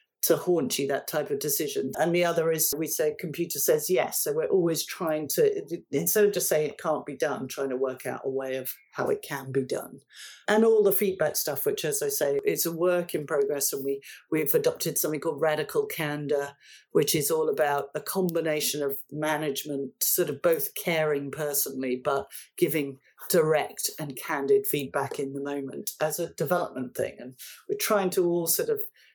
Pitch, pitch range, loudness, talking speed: 160 Hz, 140-220 Hz, -27 LUFS, 200 wpm